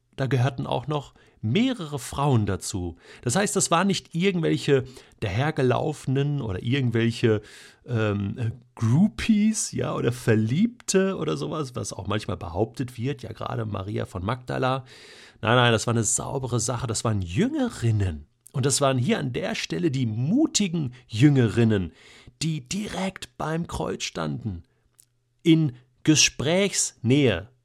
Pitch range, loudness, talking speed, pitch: 115-155 Hz, -25 LUFS, 130 wpm, 125 Hz